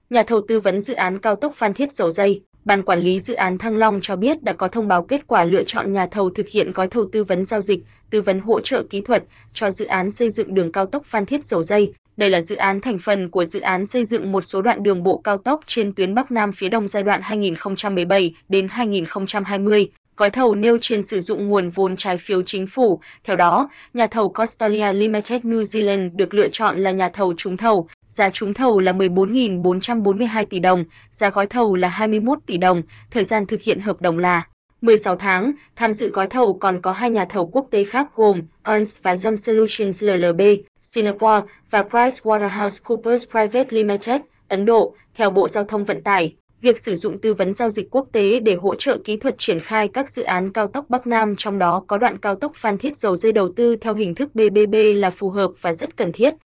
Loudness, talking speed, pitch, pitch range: -19 LUFS, 225 wpm, 205 Hz, 190-225 Hz